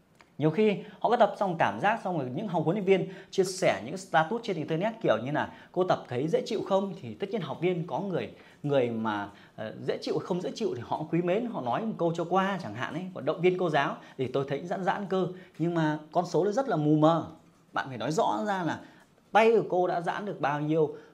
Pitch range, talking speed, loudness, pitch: 160-195 Hz, 260 wpm, -29 LUFS, 180 Hz